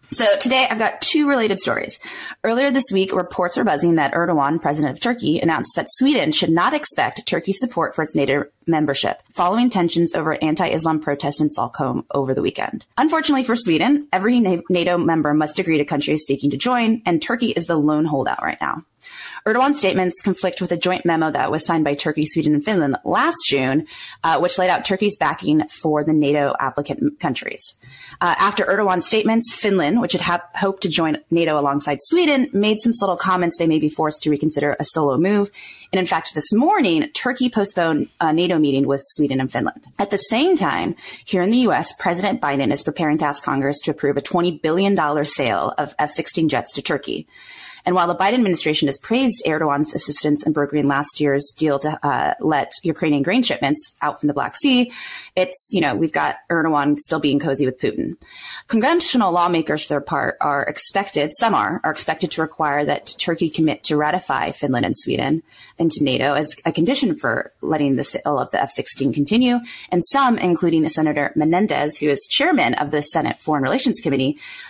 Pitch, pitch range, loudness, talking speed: 170 Hz, 150-205 Hz, -19 LUFS, 195 wpm